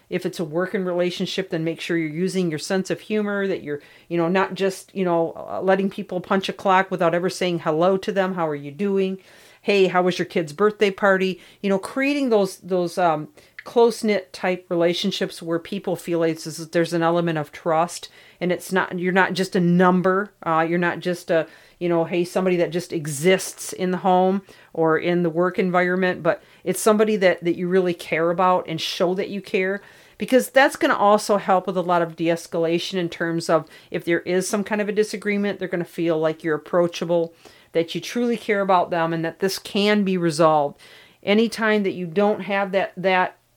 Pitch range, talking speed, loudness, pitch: 170-195 Hz, 210 wpm, -22 LUFS, 185 Hz